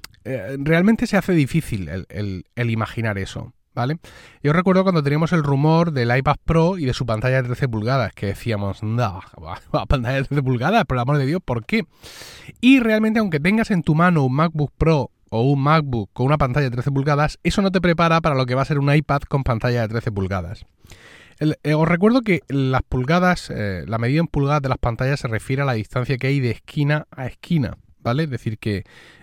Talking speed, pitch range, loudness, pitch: 220 wpm, 120-160 Hz, -20 LUFS, 140 Hz